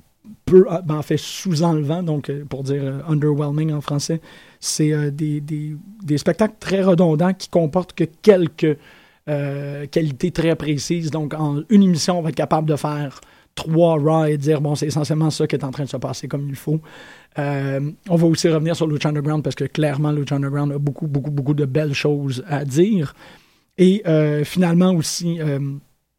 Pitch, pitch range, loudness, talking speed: 155 Hz, 145-165 Hz, -20 LUFS, 190 wpm